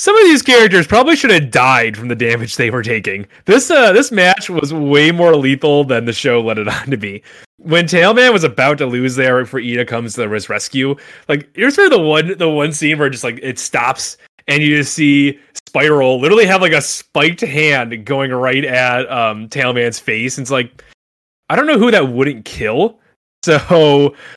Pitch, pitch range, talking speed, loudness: 140 Hz, 125-165 Hz, 205 wpm, -12 LUFS